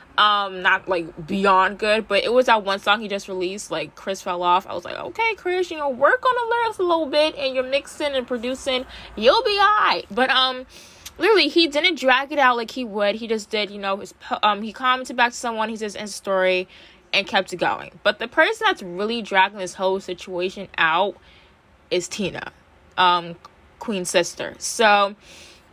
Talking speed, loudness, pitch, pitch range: 205 wpm, -21 LUFS, 215 Hz, 195-265 Hz